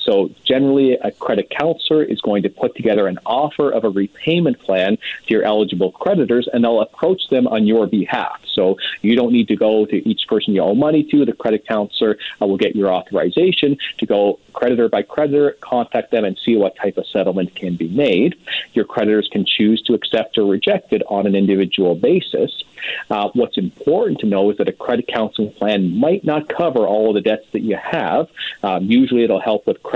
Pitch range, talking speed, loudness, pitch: 105-145 Hz, 205 wpm, -17 LUFS, 115 Hz